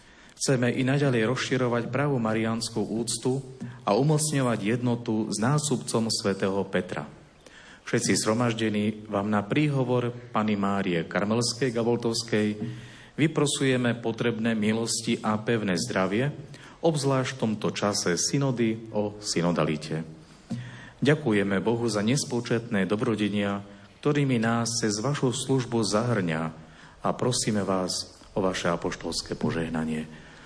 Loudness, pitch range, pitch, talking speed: -27 LUFS, 100-125 Hz, 115 Hz, 105 wpm